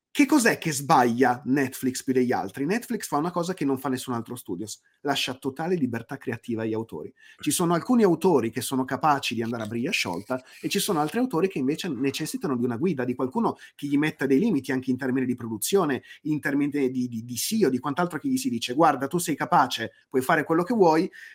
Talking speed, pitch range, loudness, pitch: 230 wpm, 125-165 Hz, -25 LUFS, 135 Hz